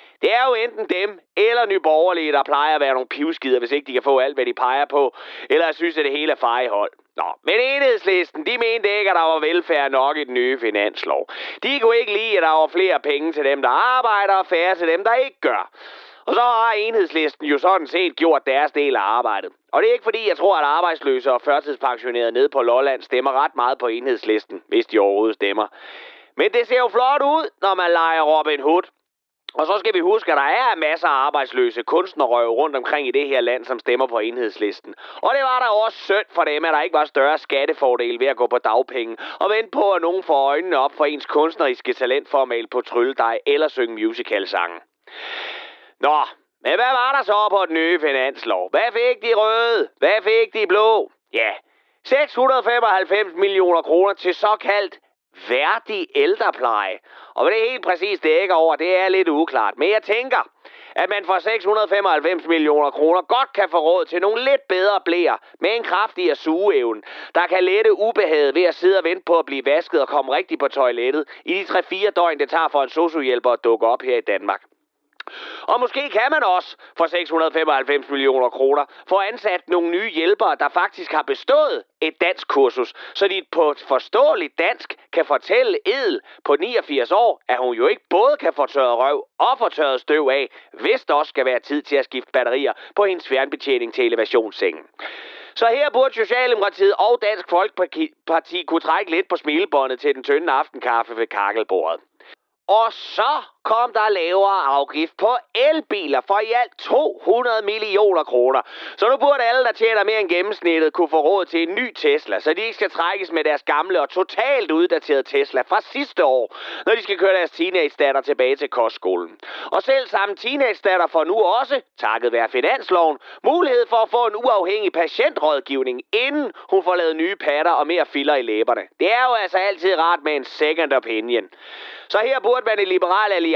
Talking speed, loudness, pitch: 200 wpm, -19 LUFS, 220 Hz